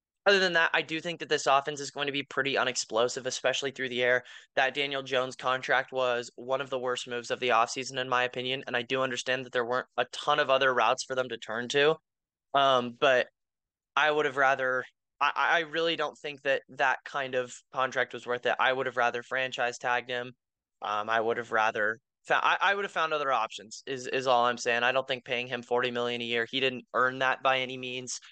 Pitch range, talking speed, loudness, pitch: 120-135 Hz, 235 wpm, -28 LUFS, 130 Hz